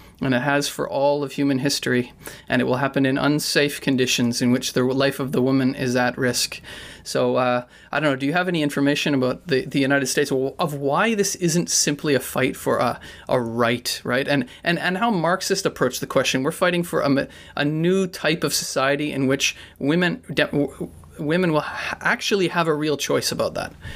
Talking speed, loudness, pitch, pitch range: 210 wpm, -21 LUFS, 140 Hz, 130-160 Hz